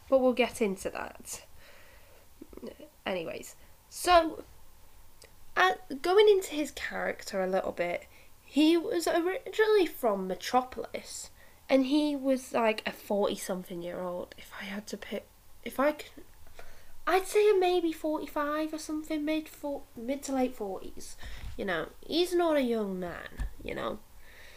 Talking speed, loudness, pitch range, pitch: 145 wpm, -30 LUFS, 220-340 Hz, 285 Hz